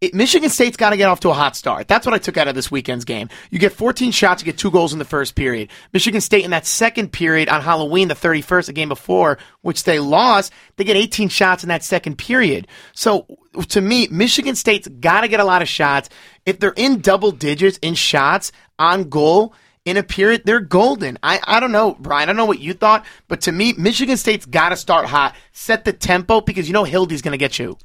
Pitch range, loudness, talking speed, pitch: 160-215 Hz, -16 LUFS, 245 wpm, 185 Hz